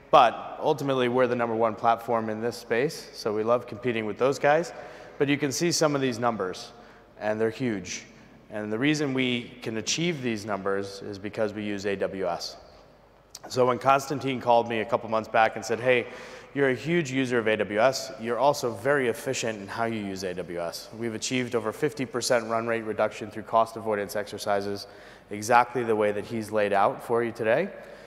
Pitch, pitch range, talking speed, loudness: 115 Hz, 105-125 Hz, 190 wpm, -27 LUFS